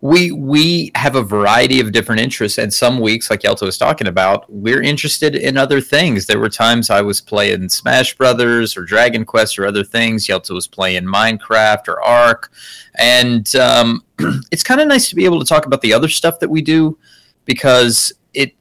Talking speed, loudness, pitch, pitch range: 195 wpm, -13 LUFS, 120 Hz, 110-150 Hz